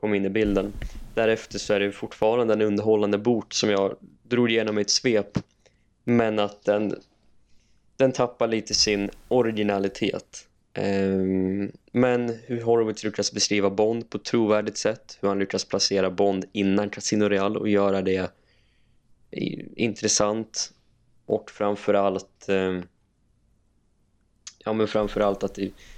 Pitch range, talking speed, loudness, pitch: 100-110 Hz, 125 wpm, -24 LUFS, 105 Hz